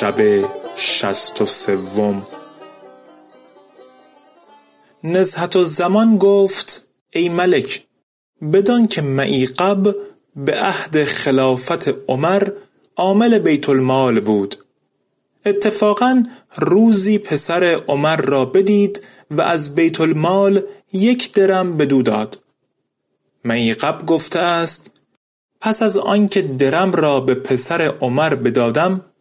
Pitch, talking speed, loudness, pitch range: 175 Hz, 100 wpm, -15 LUFS, 135-200 Hz